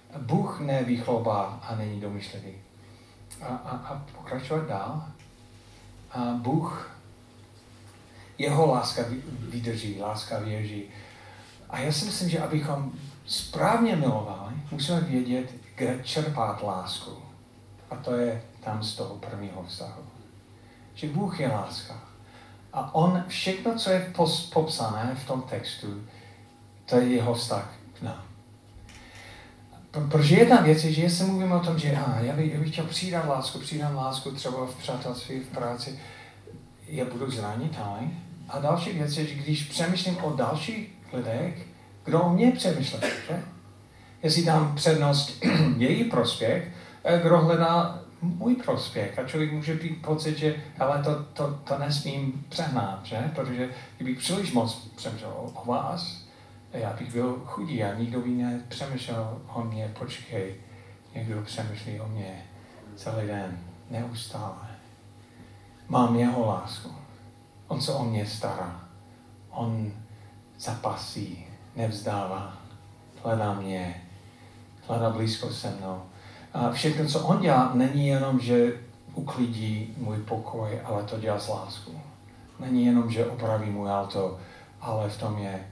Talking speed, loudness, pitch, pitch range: 135 wpm, -28 LUFS, 120 Hz, 105-140 Hz